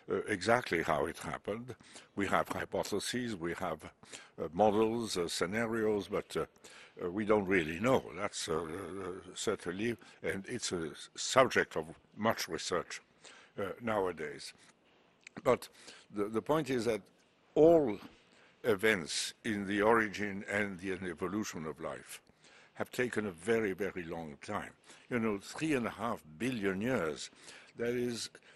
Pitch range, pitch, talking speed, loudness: 95-115 Hz, 105 Hz, 145 wpm, -34 LUFS